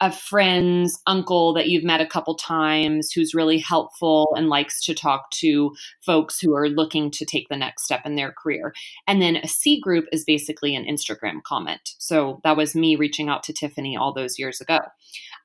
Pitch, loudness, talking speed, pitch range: 155 Hz, -21 LUFS, 200 wpm, 150-165 Hz